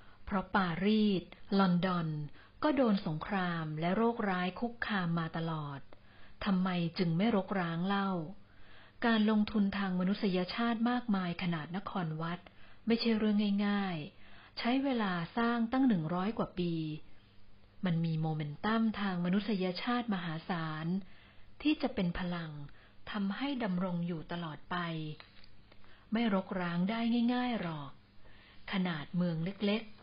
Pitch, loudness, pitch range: 185 Hz, -34 LUFS, 160-210 Hz